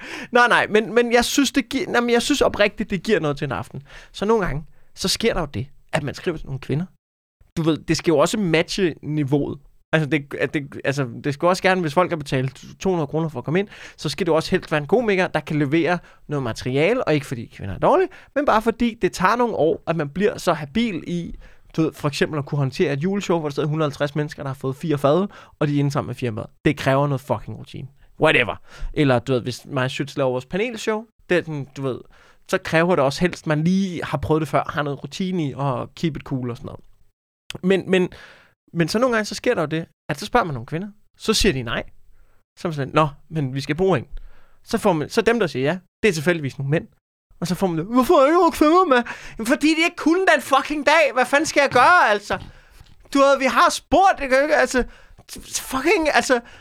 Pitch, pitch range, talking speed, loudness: 170 Hz, 145-220 Hz, 255 wpm, -21 LUFS